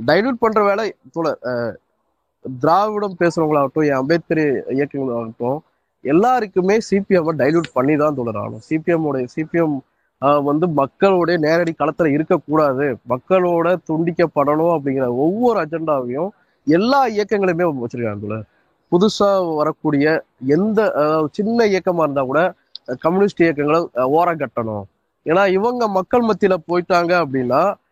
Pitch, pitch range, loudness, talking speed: 160 Hz, 140-185 Hz, -18 LUFS, 105 wpm